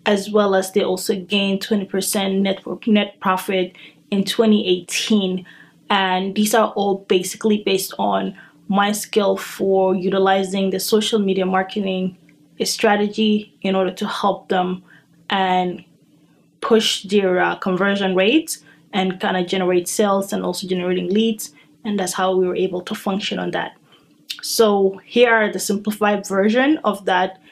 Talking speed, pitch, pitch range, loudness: 145 wpm, 195 Hz, 185-210 Hz, -19 LUFS